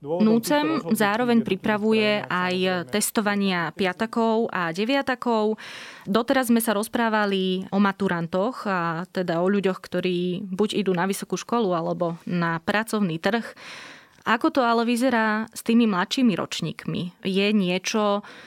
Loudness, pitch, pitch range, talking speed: -23 LUFS, 205 Hz, 185-230 Hz, 125 wpm